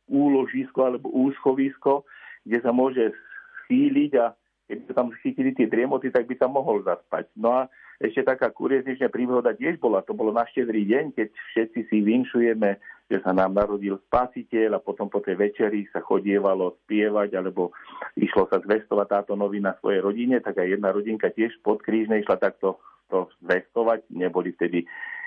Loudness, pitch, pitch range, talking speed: -24 LUFS, 115 Hz, 100-130 Hz, 165 wpm